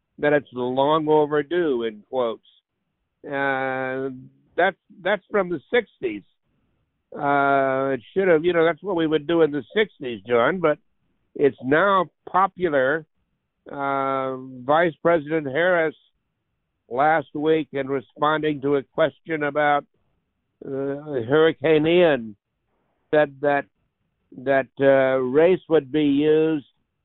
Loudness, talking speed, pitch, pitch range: -22 LUFS, 120 wpm, 150 Hz, 135-160 Hz